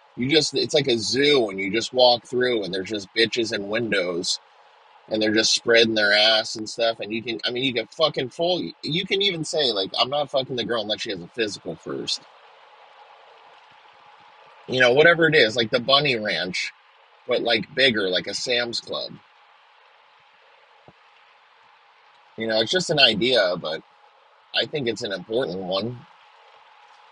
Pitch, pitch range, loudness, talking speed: 120 Hz, 110-155 Hz, -21 LUFS, 175 wpm